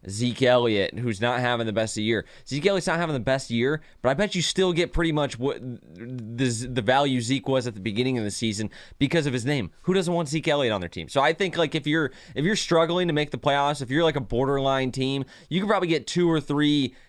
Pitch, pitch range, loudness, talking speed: 135 Hz, 120-160 Hz, -24 LUFS, 265 wpm